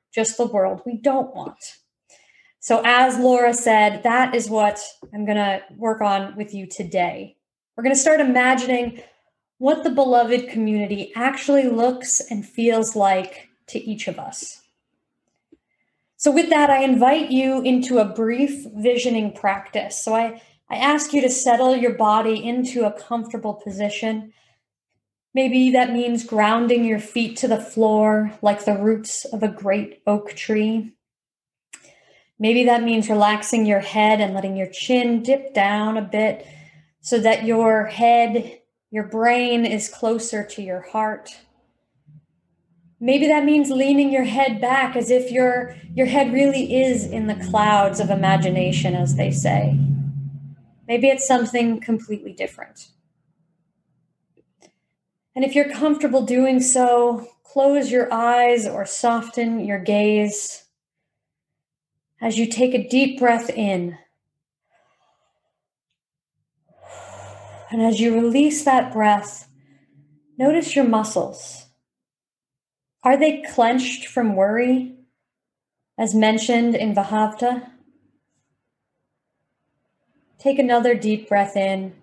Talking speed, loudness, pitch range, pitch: 130 wpm, -19 LUFS, 205-250 Hz, 225 Hz